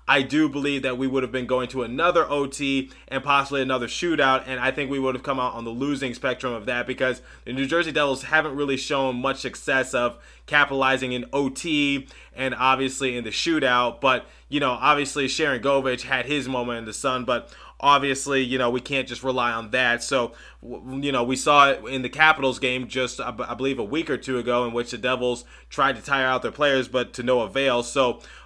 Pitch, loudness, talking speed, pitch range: 130 Hz, -23 LUFS, 220 wpm, 125-140 Hz